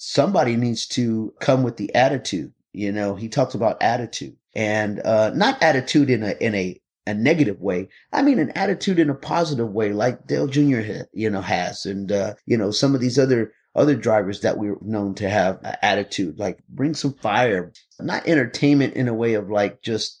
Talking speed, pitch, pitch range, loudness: 200 wpm, 115 Hz, 105-135 Hz, -21 LUFS